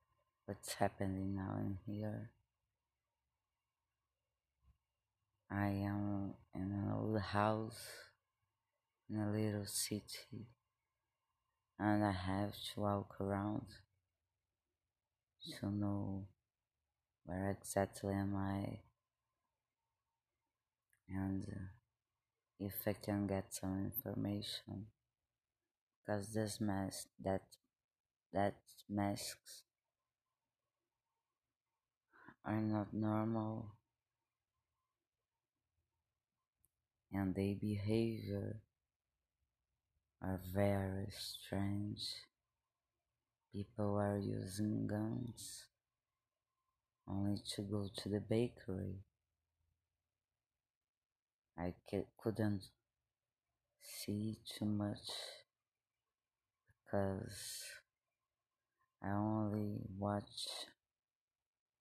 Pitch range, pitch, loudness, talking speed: 95-105 Hz, 100 Hz, -43 LUFS, 65 wpm